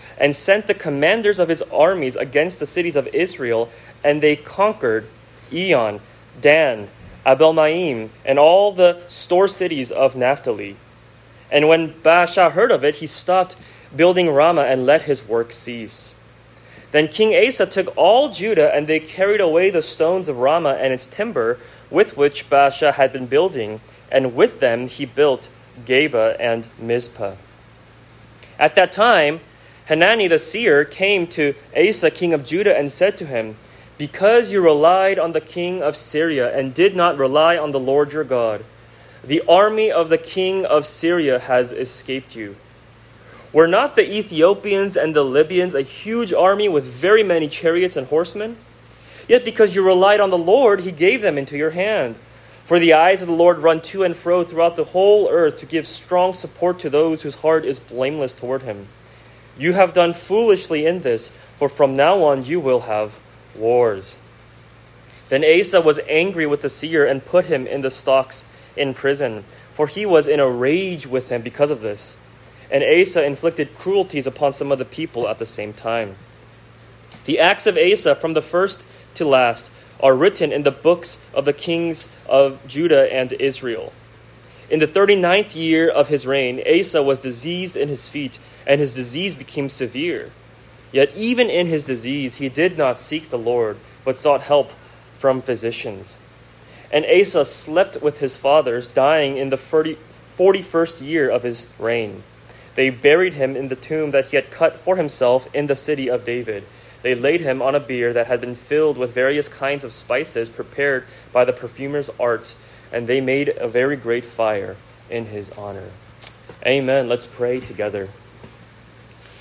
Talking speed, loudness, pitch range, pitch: 170 wpm, -18 LUFS, 125-170 Hz, 140 Hz